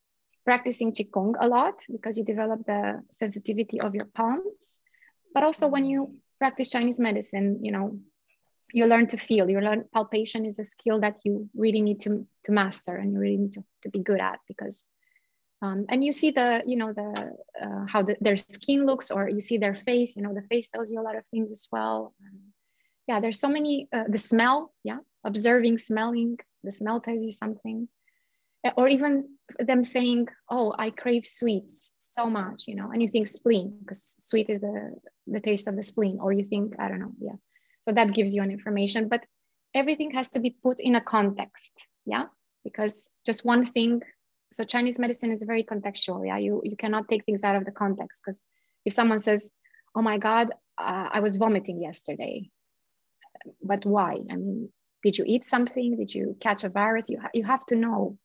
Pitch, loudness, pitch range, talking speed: 220 Hz, -27 LUFS, 205-245 Hz, 200 wpm